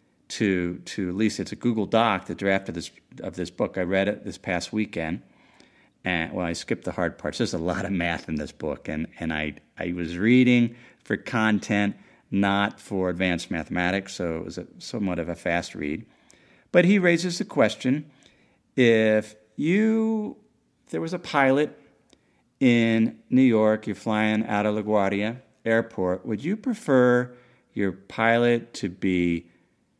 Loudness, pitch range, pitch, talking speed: -25 LUFS, 95-125 Hz, 110 Hz, 165 wpm